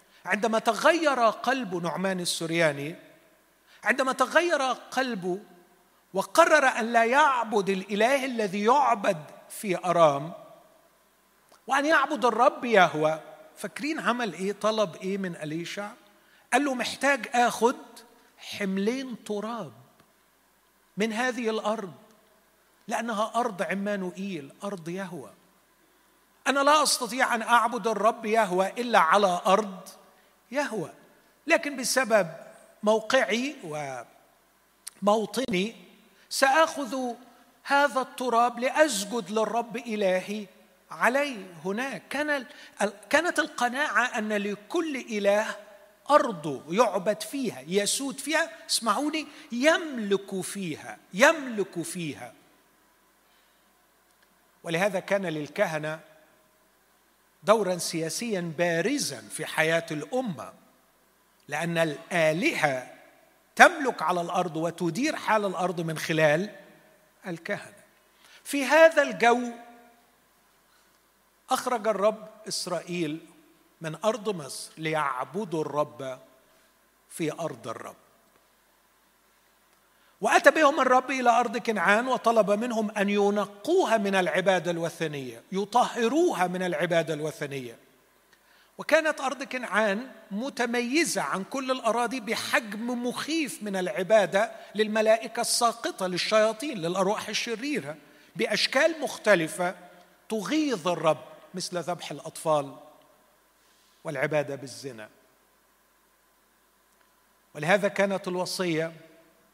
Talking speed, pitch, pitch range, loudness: 90 wpm, 215 Hz, 180-250 Hz, -26 LUFS